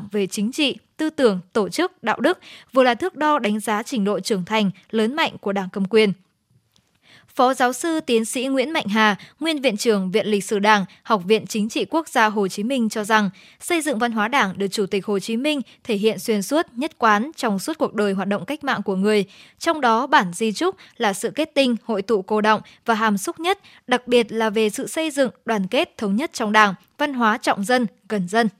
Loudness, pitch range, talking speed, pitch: -21 LUFS, 210-265 Hz, 240 wpm, 225 Hz